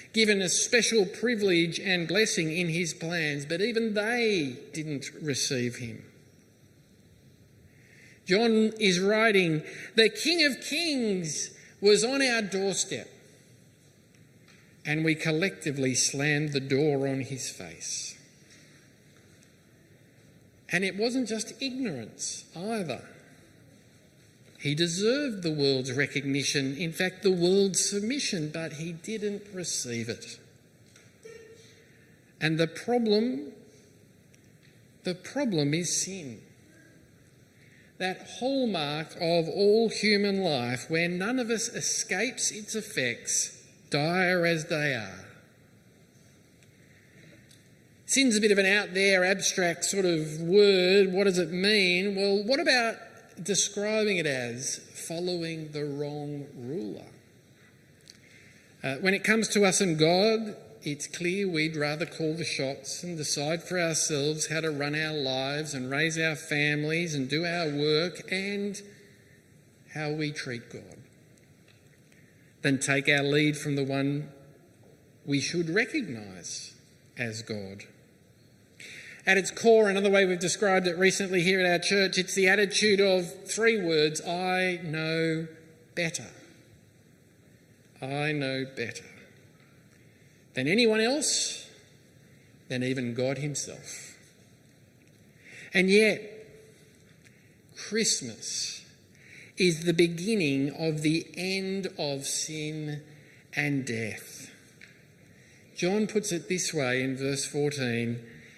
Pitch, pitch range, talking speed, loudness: 165 Hz, 145-195 Hz, 115 wpm, -27 LUFS